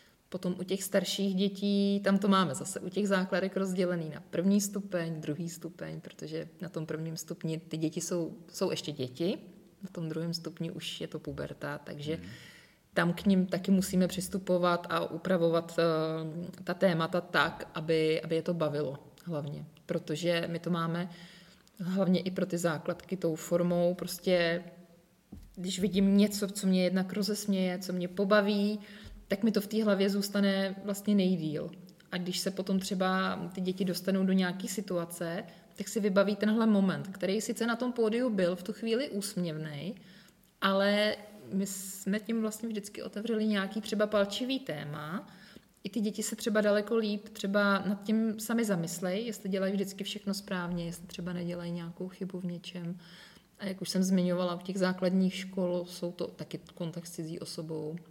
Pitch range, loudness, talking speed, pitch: 170-200 Hz, -32 LUFS, 170 wpm, 185 Hz